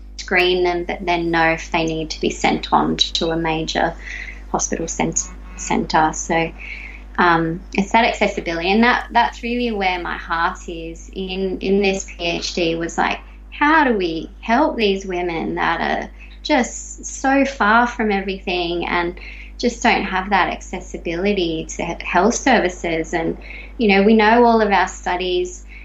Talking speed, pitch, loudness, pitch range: 160 wpm, 185 Hz, -18 LUFS, 170-215 Hz